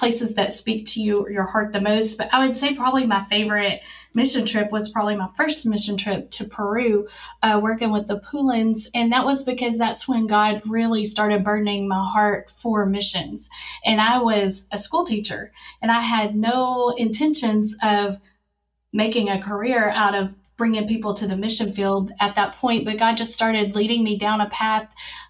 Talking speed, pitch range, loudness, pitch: 190 wpm, 205-230 Hz, -21 LUFS, 215 Hz